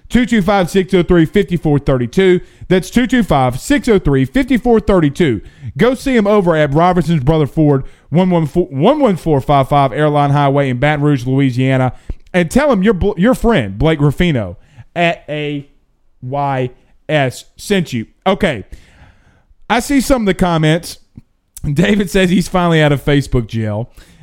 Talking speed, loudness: 125 wpm, -14 LUFS